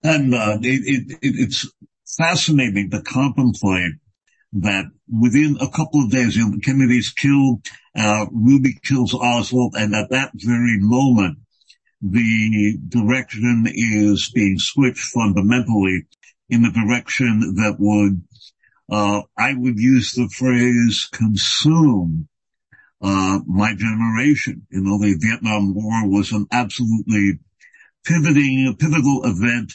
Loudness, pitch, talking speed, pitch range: -18 LUFS, 115 Hz, 115 wpm, 105-130 Hz